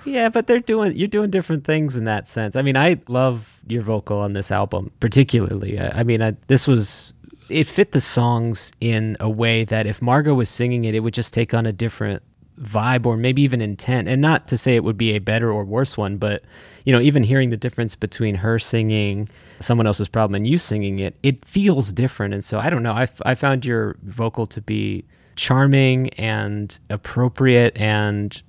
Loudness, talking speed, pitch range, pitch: -19 LUFS, 215 wpm, 105-130 Hz, 115 Hz